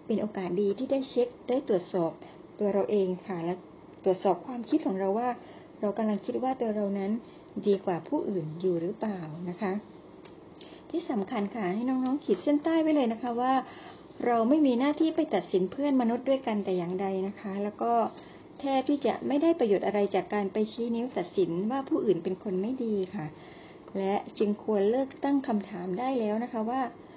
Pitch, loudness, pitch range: 215 Hz, -28 LUFS, 195-260 Hz